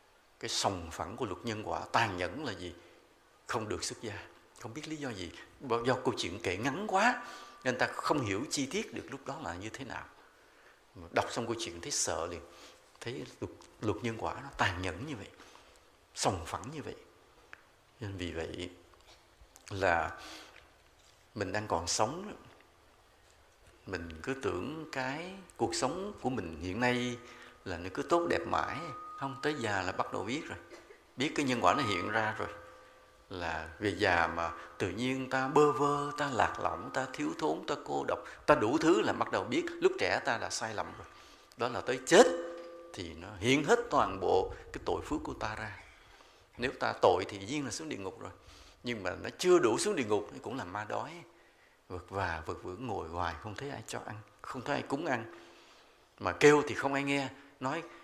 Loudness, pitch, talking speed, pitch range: -33 LUFS, 115 Hz, 200 wpm, 90-145 Hz